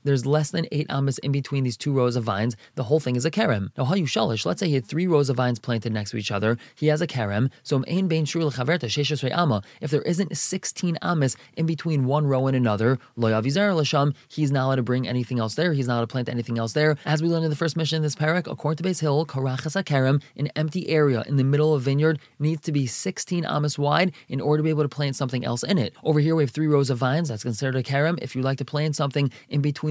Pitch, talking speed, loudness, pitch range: 145 Hz, 255 wpm, -24 LUFS, 130-155 Hz